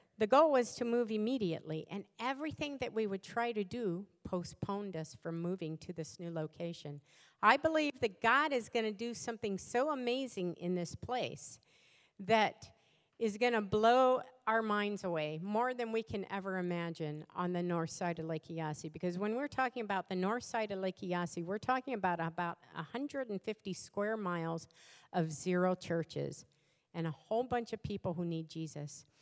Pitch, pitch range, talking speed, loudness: 190 Hz, 165-230 Hz, 180 wpm, -36 LUFS